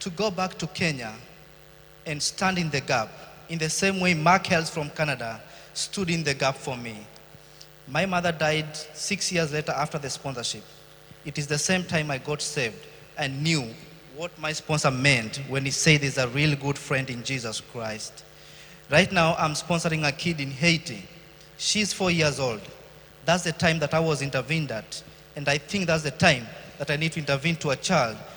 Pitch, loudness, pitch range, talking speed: 150 Hz, -25 LUFS, 140-165 Hz, 195 wpm